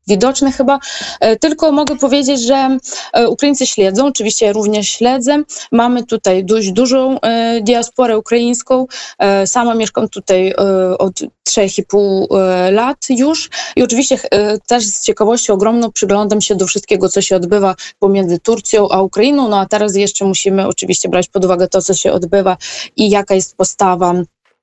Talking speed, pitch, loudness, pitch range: 145 wpm, 215 Hz, -12 LUFS, 195-250 Hz